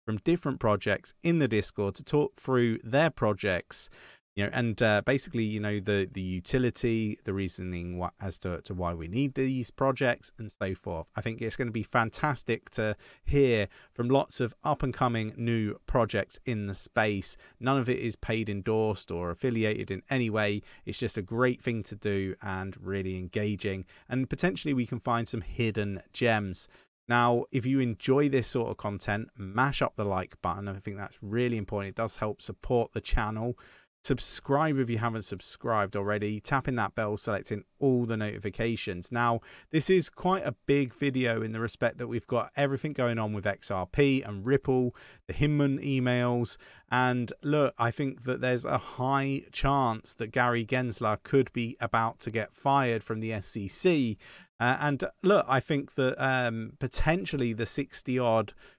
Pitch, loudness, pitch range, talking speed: 115 Hz, -30 LUFS, 105-130 Hz, 180 wpm